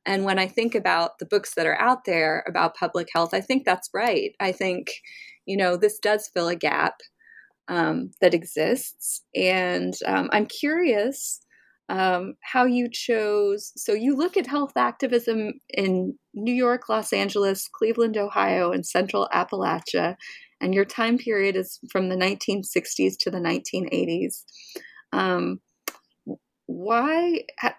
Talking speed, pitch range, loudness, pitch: 145 wpm, 190-255 Hz, -24 LUFS, 210 Hz